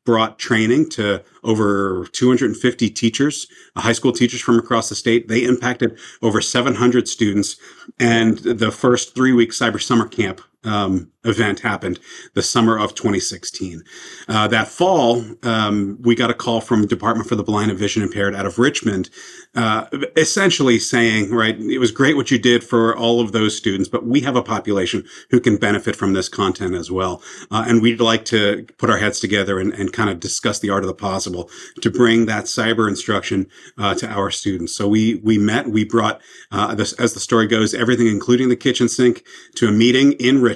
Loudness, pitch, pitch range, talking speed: -18 LUFS, 115 Hz, 105-120 Hz, 190 wpm